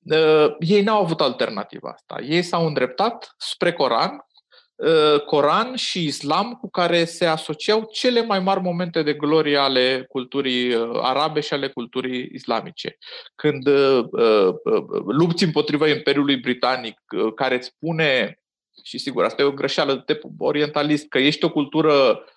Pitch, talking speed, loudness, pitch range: 155 Hz, 145 wpm, -20 LUFS, 140-210 Hz